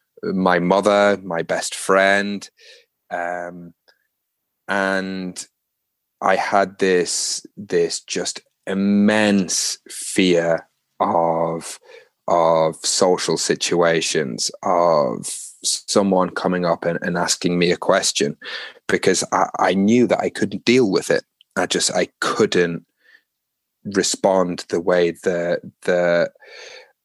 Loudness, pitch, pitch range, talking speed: -19 LUFS, 90 Hz, 85-100 Hz, 105 wpm